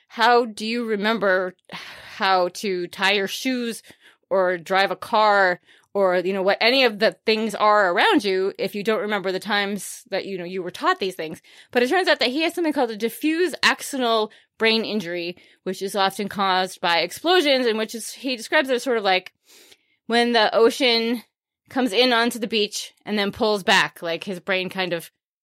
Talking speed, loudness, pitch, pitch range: 200 wpm, -21 LUFS, 215 Hz, 190-240 Hz